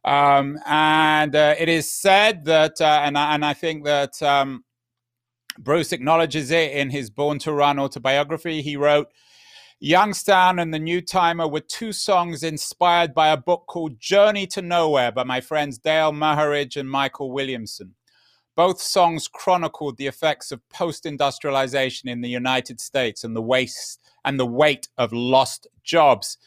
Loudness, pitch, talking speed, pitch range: -20 LUFS, 150 Hz, 160 wpm, 135-165 Hz